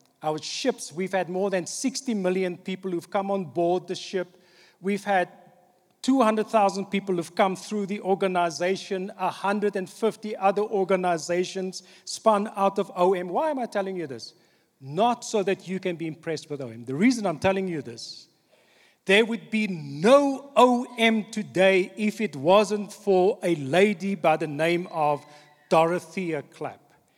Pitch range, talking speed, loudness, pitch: 175-205 Hz, 155 wpm, -25 LUFS, 190 Hz